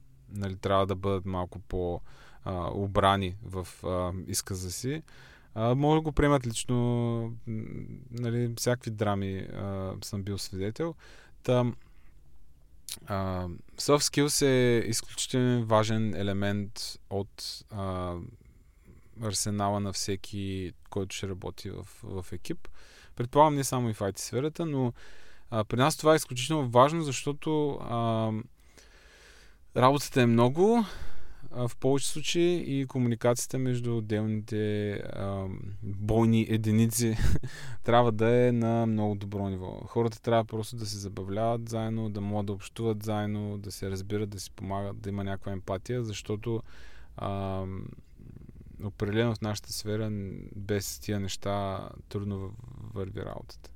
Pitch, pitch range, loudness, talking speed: 110 Hz, 100-120 Hz, -30 LUFS, 125 wpm